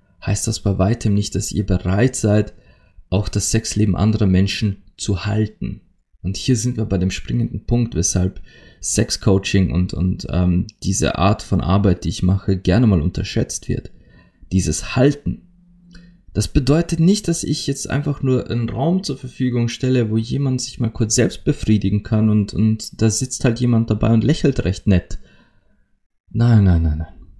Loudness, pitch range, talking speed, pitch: -19 LUFS, 95-120 Hz, 170 wpm, 105 Hz